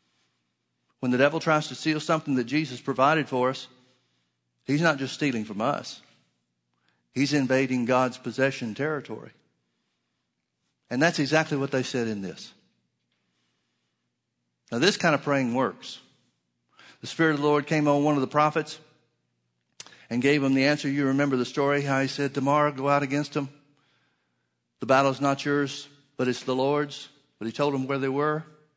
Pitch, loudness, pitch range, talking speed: 135 Hz, -25 LUFS, 95-145 Hz, 170 wpm